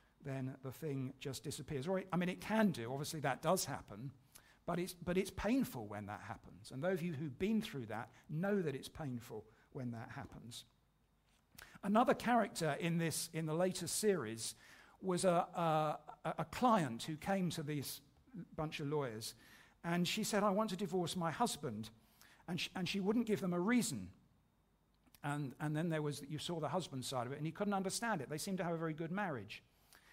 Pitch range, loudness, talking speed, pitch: 135-185 Hz, -40 LUFS, 205 wpm, 160 Hz